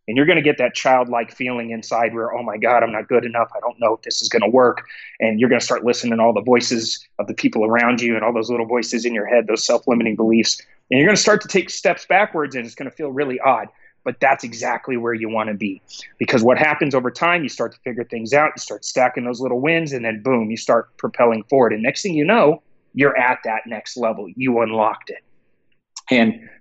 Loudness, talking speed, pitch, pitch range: -18 LUFS, 255 wpm, 120 Hz, 115-130 Hz